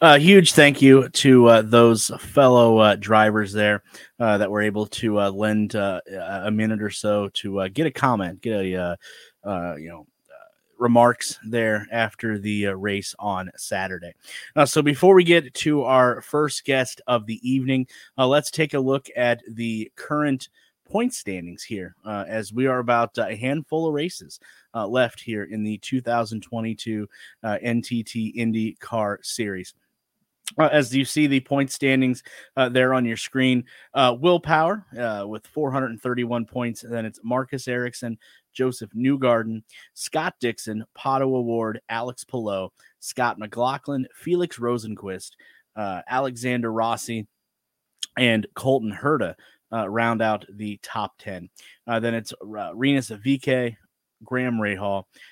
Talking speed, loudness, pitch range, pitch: 155 wpm, -22 LUFS, 110-135 Hz, 120 Hz